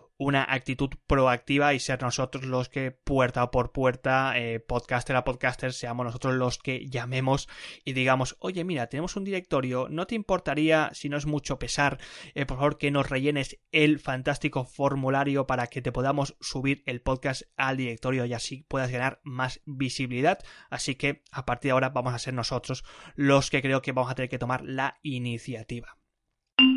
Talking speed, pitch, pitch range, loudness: 180 wpm, 135 Hz, 125-140 Hz, -28 LUFS